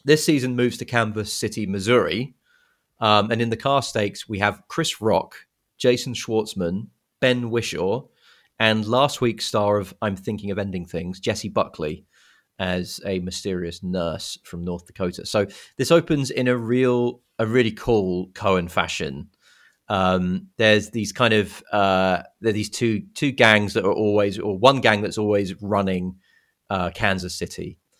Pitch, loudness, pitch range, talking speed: 105 Hz, -22 LUFS, 95-120 Hz, 160 wpm